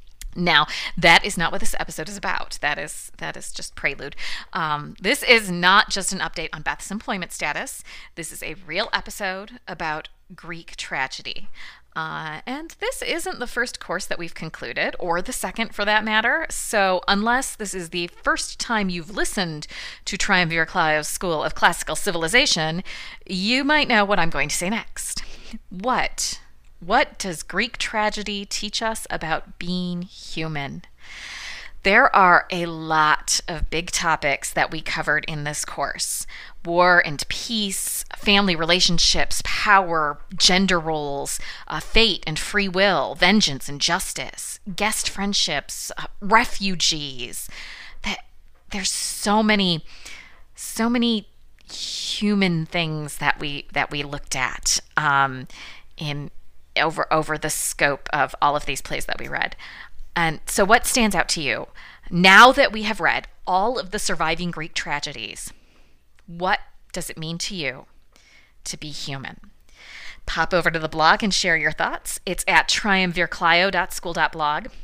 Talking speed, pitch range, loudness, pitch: 150 wpm, 155-210 Hz, -21 LUFS, 180 Hz